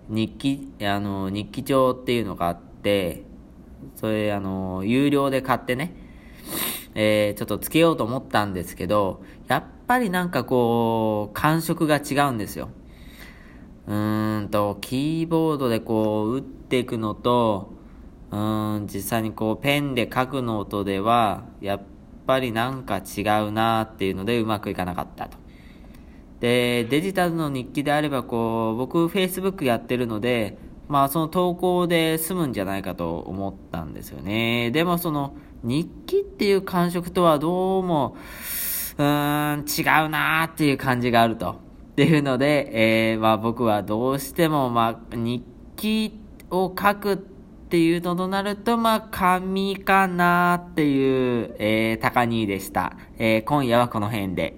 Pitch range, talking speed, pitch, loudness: 105-160 Hz, 295 characters per minute, 125 Hz, -23 LUFS